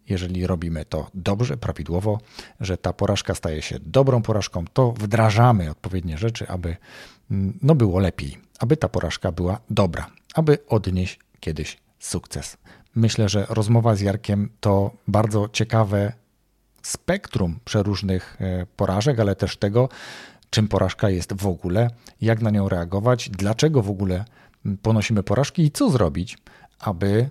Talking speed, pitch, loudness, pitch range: 135 wpm, 105 Hz, -22 LUFS, 95-115 Hz